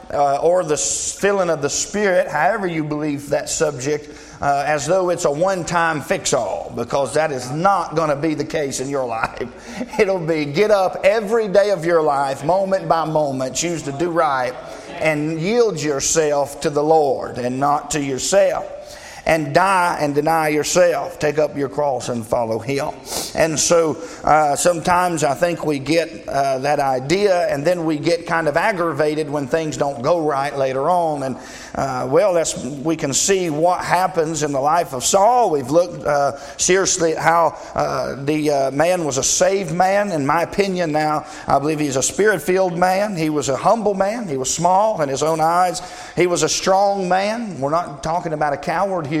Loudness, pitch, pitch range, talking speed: -18 LUFS, 160 Hz, 145-180 Hz, 195 wpm